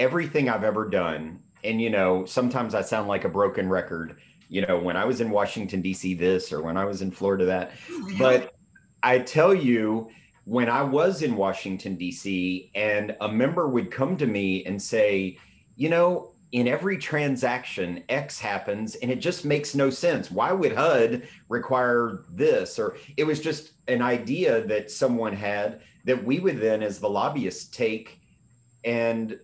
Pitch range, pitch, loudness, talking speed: 95-130 Hz, 115 Hz, -25 LUFS, 175 wpm